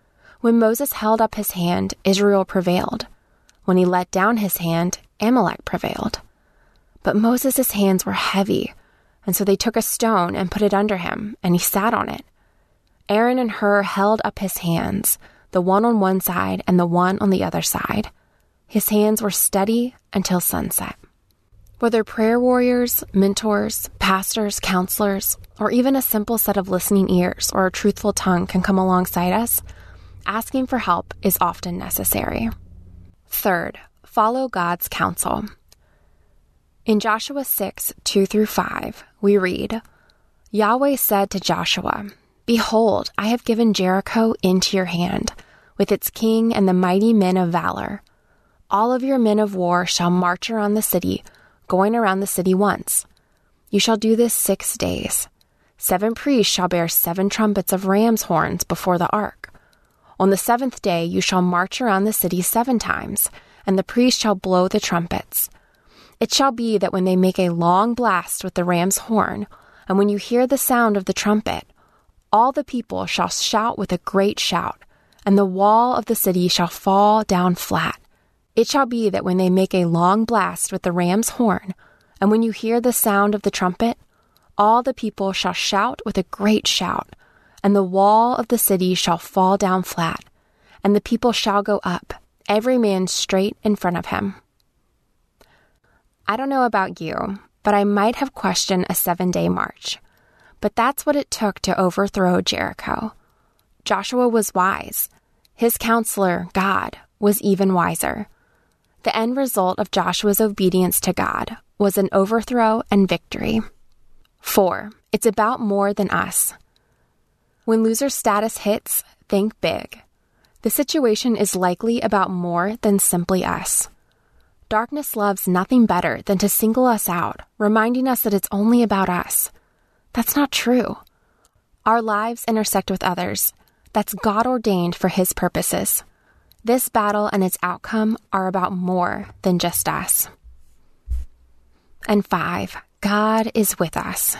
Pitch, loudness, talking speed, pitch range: 200 Hz, -19 LUFS, 160 wpm, 185-225 Hz